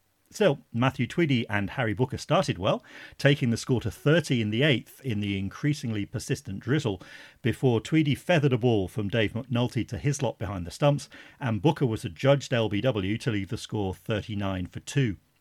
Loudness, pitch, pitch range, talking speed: -27 LUFS, 120 Hz, 105-140 Hz, 185 wpm